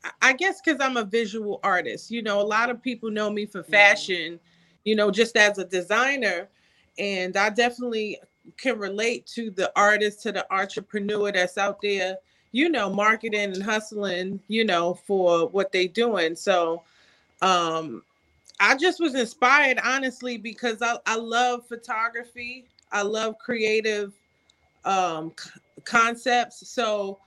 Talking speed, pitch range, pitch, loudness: 145 wpm, 195-235 Hz, 210 Hz, -23 LUFS